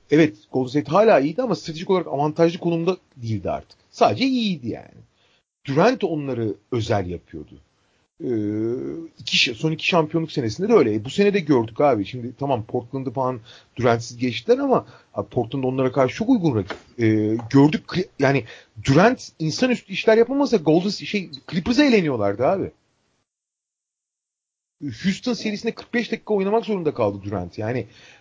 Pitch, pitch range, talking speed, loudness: 150 Hz, 120-200 Hz, 145 wpm, -21 LUFS